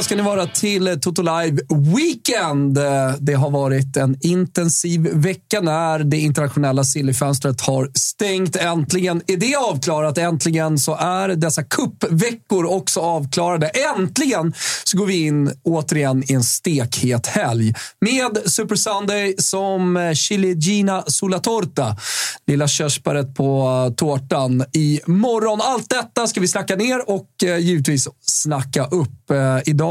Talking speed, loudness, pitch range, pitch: 130 wpm, -18 LUFS, 140-190 Hz, 165 Hz